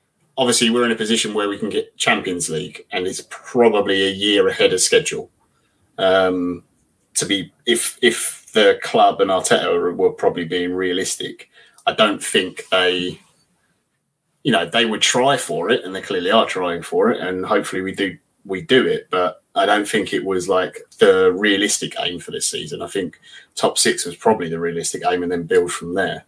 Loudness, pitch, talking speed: -18 LUFS, 100 Hz, 190 wpm